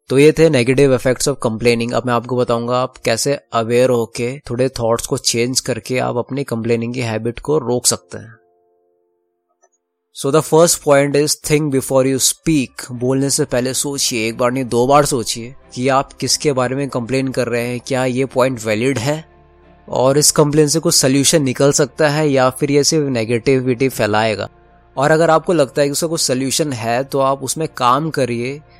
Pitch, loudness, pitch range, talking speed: 130 Hz, -16 LUFS, 120-145 Hz, 190 wpm